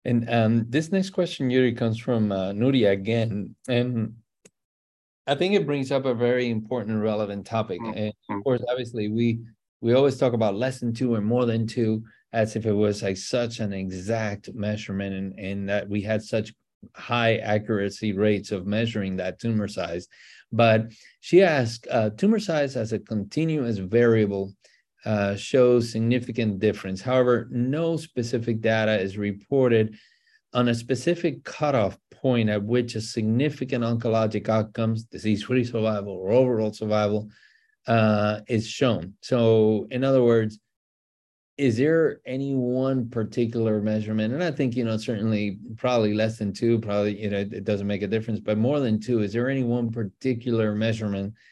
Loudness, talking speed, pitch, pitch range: -25 LUFS, 160 wpm, 110 Hz, 105-125 Hz